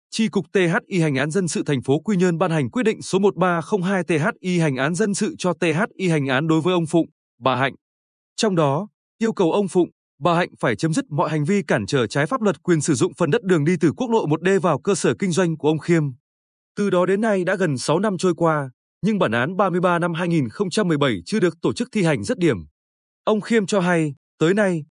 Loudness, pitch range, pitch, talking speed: -21 LUFS, 155-200 Hz, 180 Hz, 240 wpm